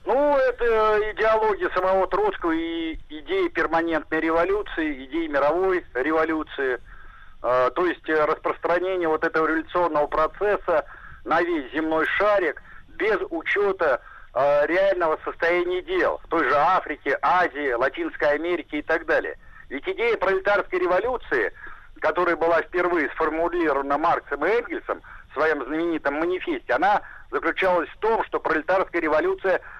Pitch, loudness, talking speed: 190 Hz, -23 LUFS, 120 wpm